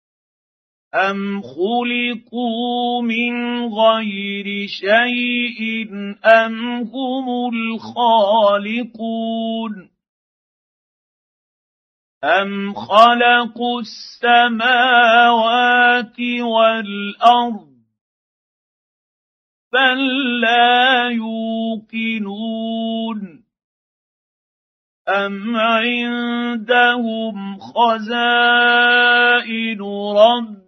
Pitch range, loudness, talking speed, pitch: 225-240 Hz, -16 LUFS, 35 wpm, 230 Hz